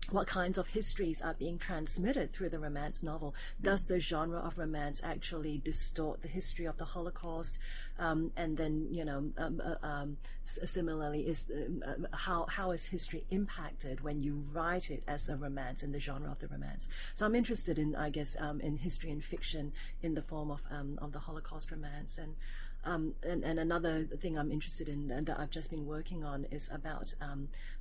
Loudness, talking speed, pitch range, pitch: -39 LUFS, 195 wpm, 145-170 Hz, 155 Hz